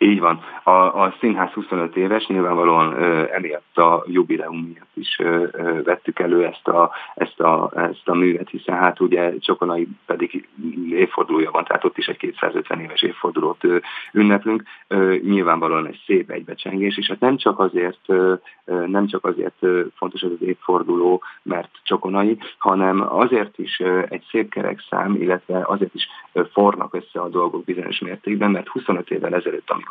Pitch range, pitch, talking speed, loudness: 90-110 Hz, 95 Hz, 165 wpm, -20 LUFS